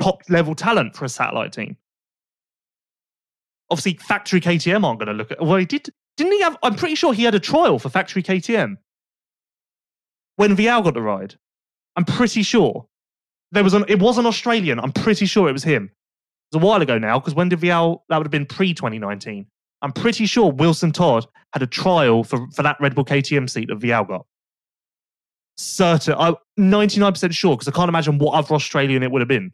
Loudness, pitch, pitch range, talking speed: -18 LUFS, 170 Hz, 135-205 Hz, 205 wpm